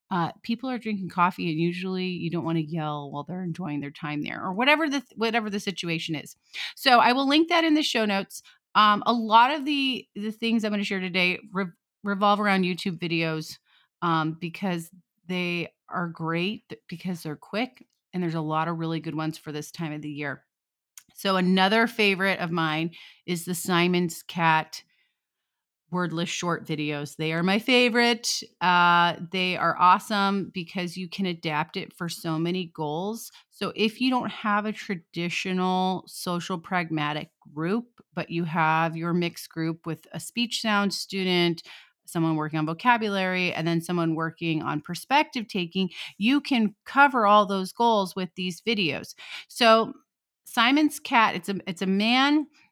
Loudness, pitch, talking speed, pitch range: -25 LUFS, 185 Hz, 175 wpm, 165-215 Hz